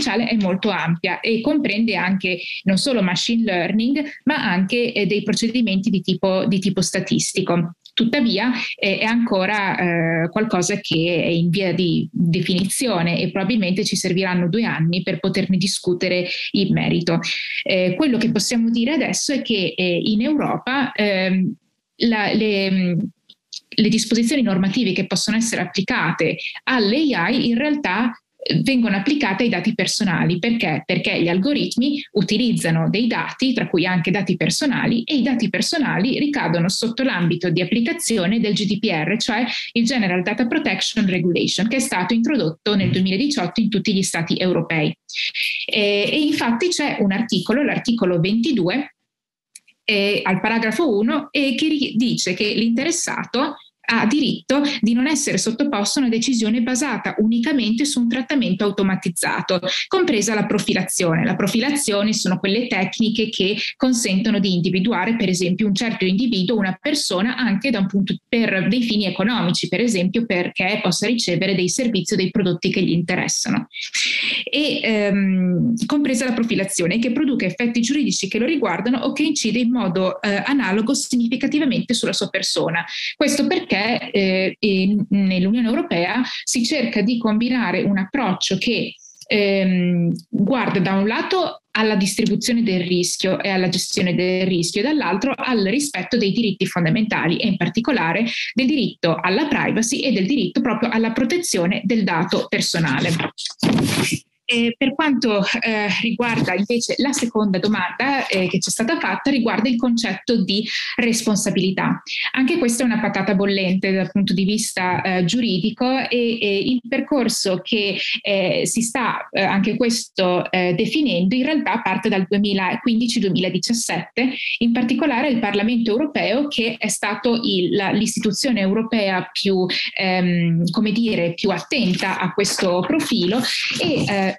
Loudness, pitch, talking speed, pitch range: -19 LUFS, 215 Hz, 150 wpm, 190-245 Hz